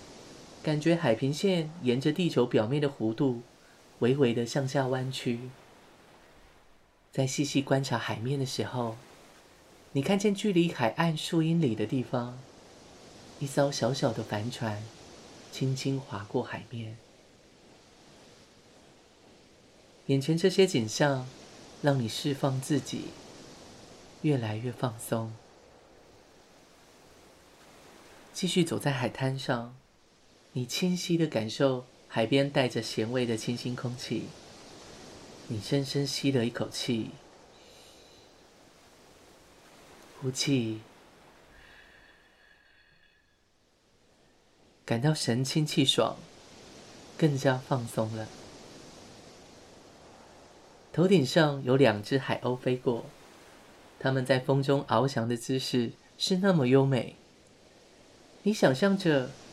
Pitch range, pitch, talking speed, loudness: 120-145 Hz, 135 Hz, 150 characters per minute, -29 LUFS